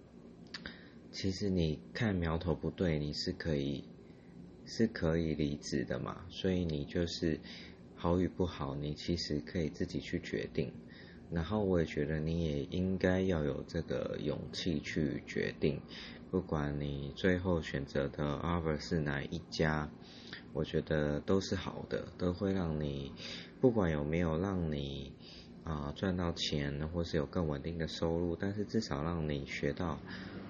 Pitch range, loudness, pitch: 75-90 Hz, -36 LUFS, 80 Hz